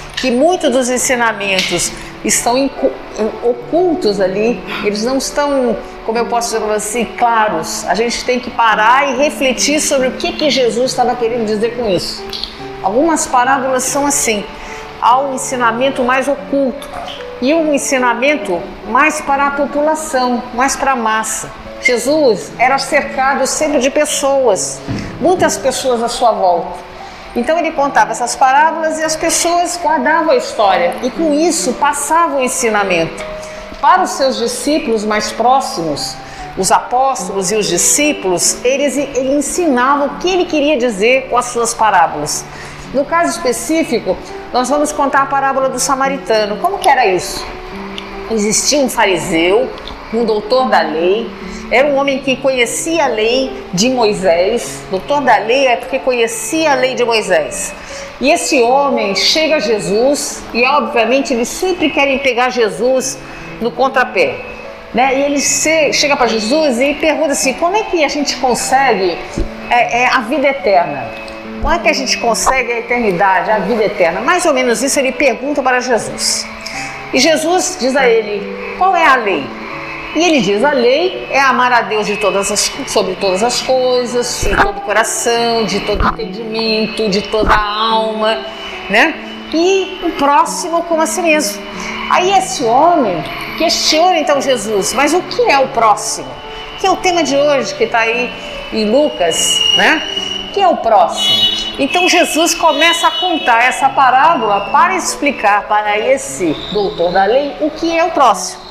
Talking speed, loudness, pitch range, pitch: 160 wpm, -13 LUFS, 225-300 Hz, 260 Hz